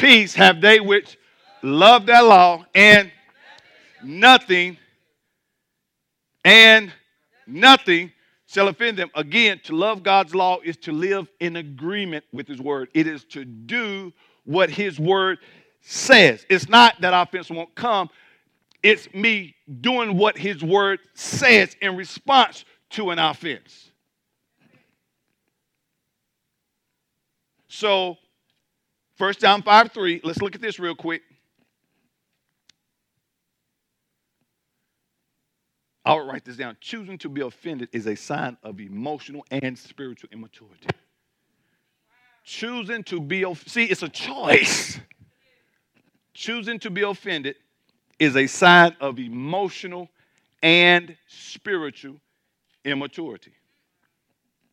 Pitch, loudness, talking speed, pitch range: 185 Hz, -16 LUFS, 110 wpm, 160-210 Hz